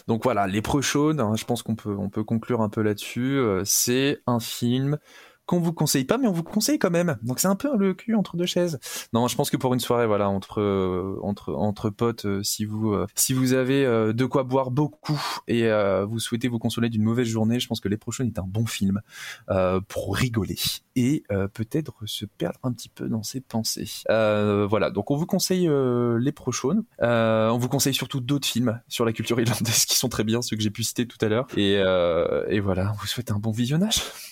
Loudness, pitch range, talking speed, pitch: -24 LUFS, 105-140 Hz, 240 wpm, 120 Hz